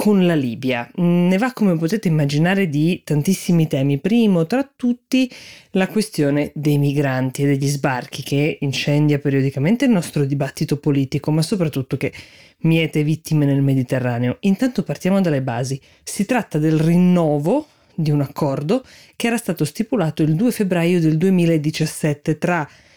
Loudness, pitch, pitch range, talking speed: -19 LUFS, 155 Hz, 145-190 Hz, 145 wpm